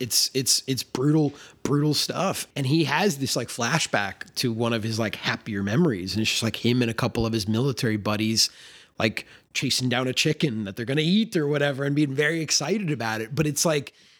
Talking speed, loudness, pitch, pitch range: 220 wpm, -24 LUFS, 130 Hz, 115-150 Hz